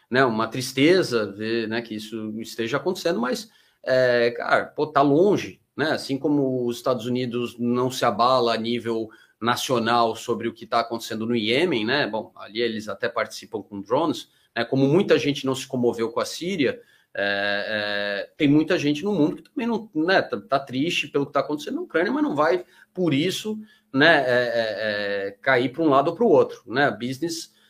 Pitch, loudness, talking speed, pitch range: 125 Hz, -23 LUFS, 195 wpm, 115-150 Hz